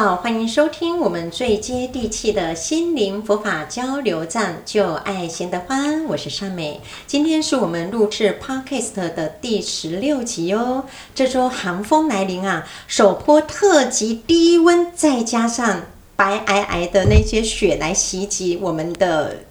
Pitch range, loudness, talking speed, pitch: 185-265 Hz, -19 LUFS, 235 characters per minute, 215 Hz